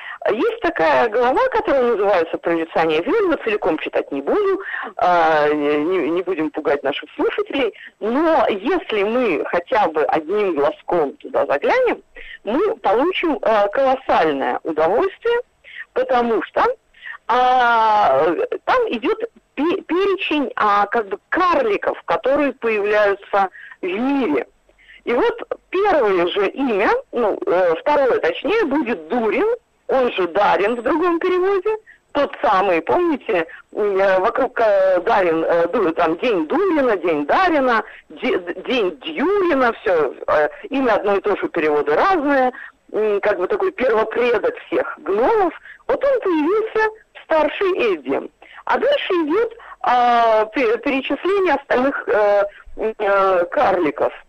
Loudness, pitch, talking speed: -18 LUFS, 315 Hz, 105 wpm